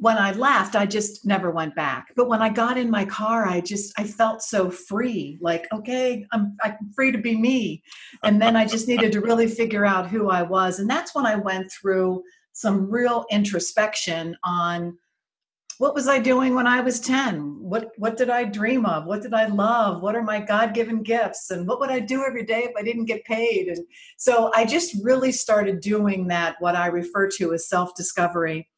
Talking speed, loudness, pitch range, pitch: 210 wpm, -22 LUFS, 190-235 Hz, 215 Hz